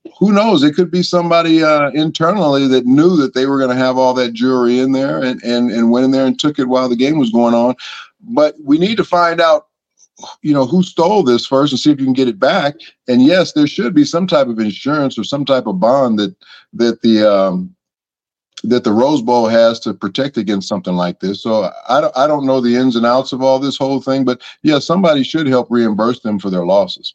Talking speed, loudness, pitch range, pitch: 240 wpm, -13 LUFS, 120-155 Hz, 130 Hz